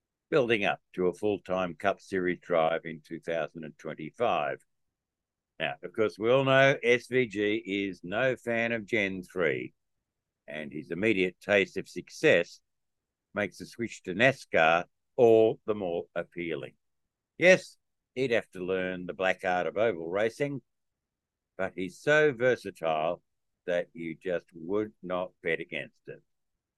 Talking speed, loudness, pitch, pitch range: 140 wpm, -29 LUFS, 95 Hz, 90-115 Hz